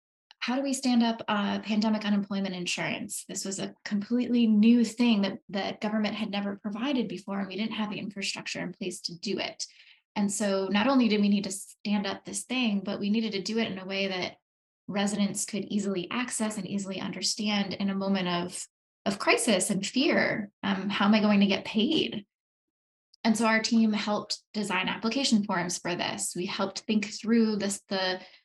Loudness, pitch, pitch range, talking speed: -28 LUFS, 205 Hz, 195-220 Hz, 200 wpm